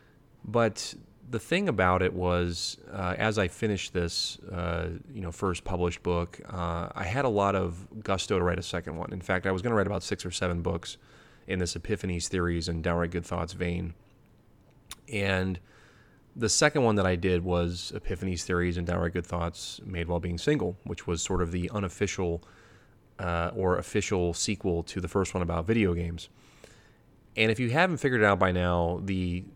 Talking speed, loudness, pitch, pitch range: 195 wpm, -29 LUFS, 90 Hz, 85-105 Hz